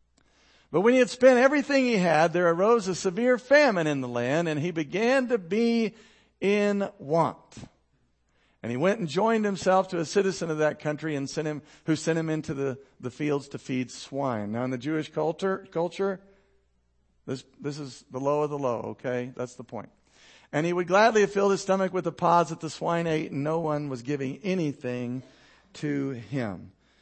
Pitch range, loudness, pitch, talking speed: 135-195 Hz, -26 LUFS, 160 Hz, 200 wpm